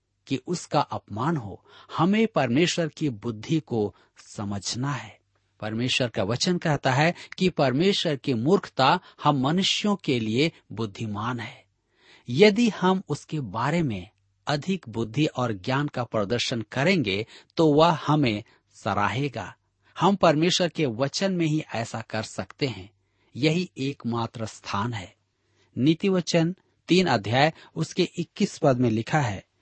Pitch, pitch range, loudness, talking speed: 135 Hz, 110-165 Hz, -25 LUFS, 135 wpm